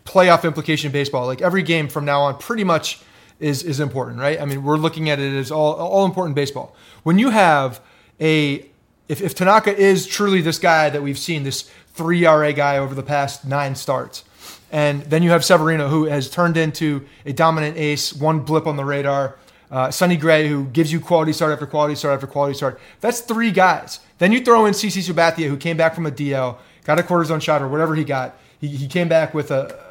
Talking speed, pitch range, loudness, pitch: 225 wpm, 140-170 Hz, -18 LUFS, 155 Hz